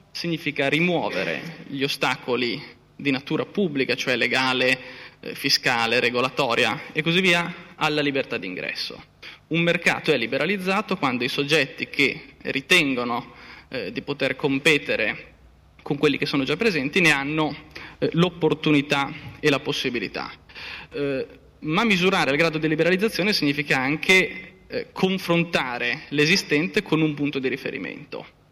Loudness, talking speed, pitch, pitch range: -22 LUFS, 125 wpm, 150 Hz, 135-170 Hz